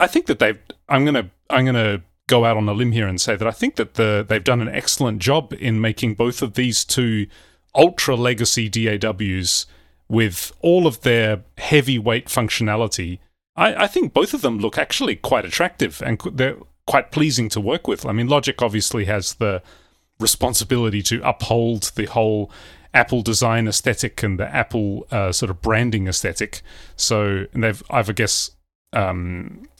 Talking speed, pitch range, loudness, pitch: 180 wpm, 100-120 Hz, -19 LUFS, 110 Hz